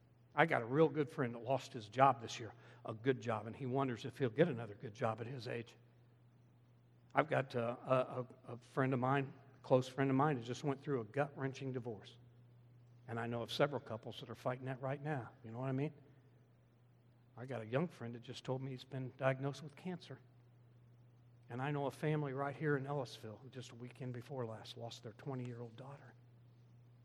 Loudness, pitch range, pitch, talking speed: -40 LUFS, 120-135 Hz, 125 Hz, 220 wpm